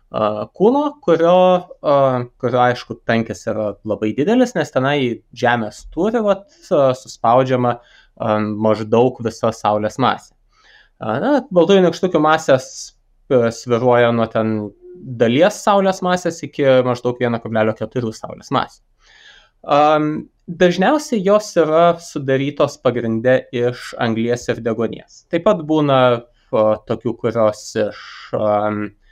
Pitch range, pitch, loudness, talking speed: 115-170 Hz, 125 Hz, -17 LUFS, 95 wpm